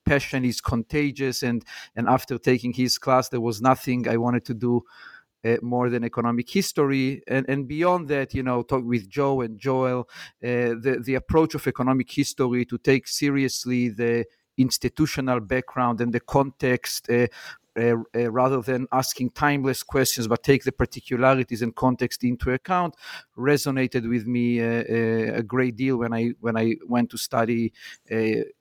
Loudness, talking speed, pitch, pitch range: -24 LUFS, 170 wpm, 125 Hz, 120-135 Hz